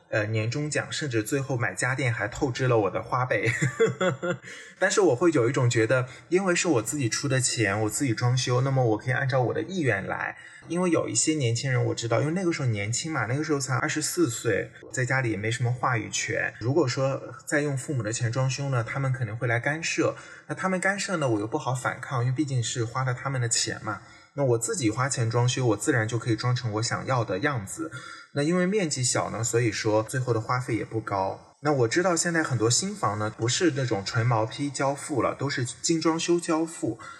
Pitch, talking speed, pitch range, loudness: 130 Hz, 330 characters per minute, 115-155 Hz, -26 LUFS